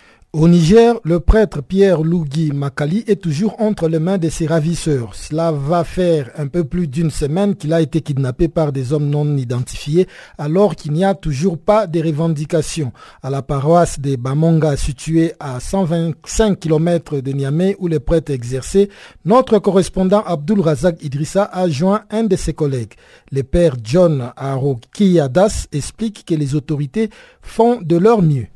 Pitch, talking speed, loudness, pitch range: 165 Hz, 165 wpm, -16 LUFS, 145-185 Hz